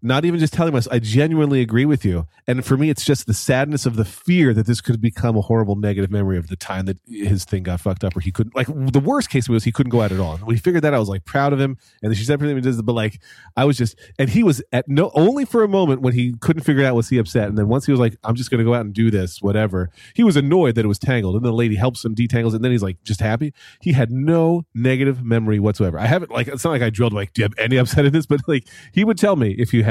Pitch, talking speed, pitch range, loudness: 120 Hz, 310 wpm, 110-140 Hz, -19 LUFS